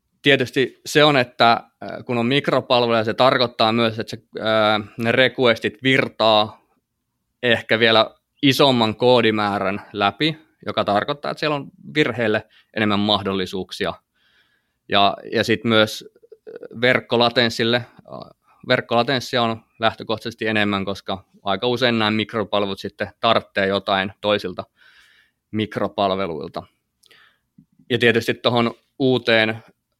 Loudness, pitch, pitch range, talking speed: -19 LUFS, 115 Hz, 105-125 Hz, 100 wpm